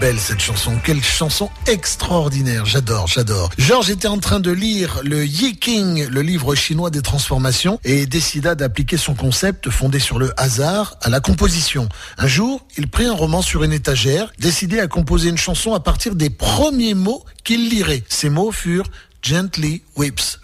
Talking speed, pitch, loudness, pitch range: 175 wpm, 155 Hz, -17 LUFS, 135-190 Hz